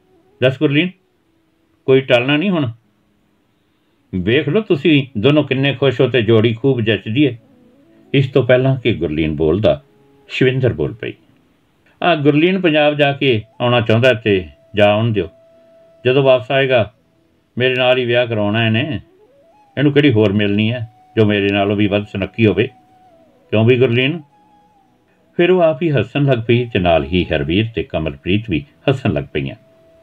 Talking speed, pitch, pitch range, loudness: 155 wpm, 125 Hz, 105-145 Hz, -15 LUFS